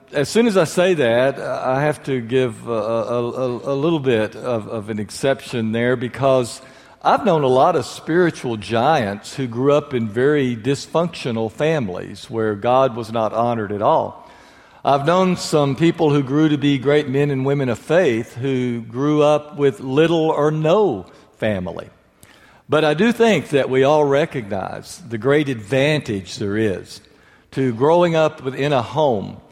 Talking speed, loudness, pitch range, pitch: 170 wpm, -19 LUFS, 120-150 Hz, 135 Hz